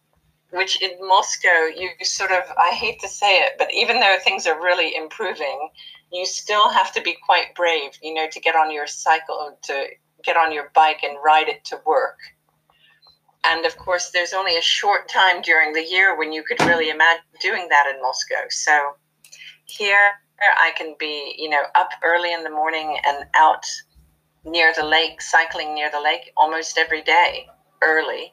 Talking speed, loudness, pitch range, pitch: 185 wpm, -18 LUFS, 155-185 Hz, 160 Hz